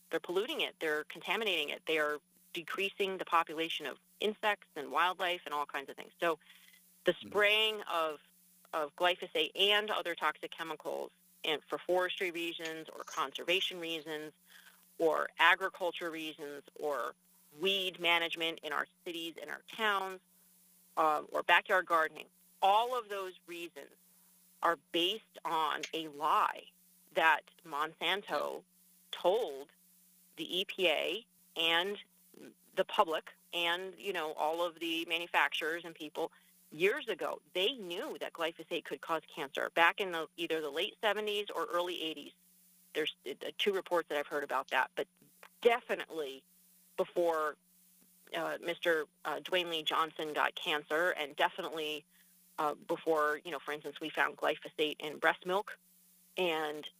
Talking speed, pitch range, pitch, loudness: 140 wpm, 160-185 Hz, 175 Hz, -34 LUFS